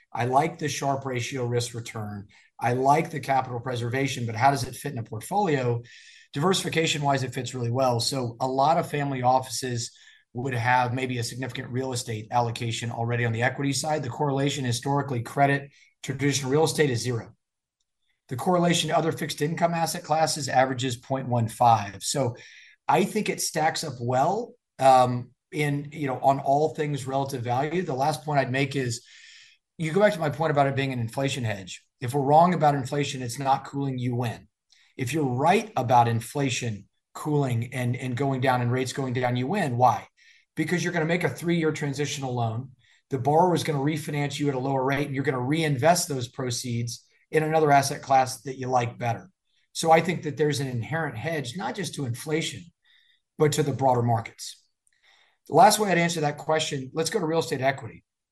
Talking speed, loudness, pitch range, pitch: 195 wpm, -25 LUFS, 125-155 Hz, 135 Hz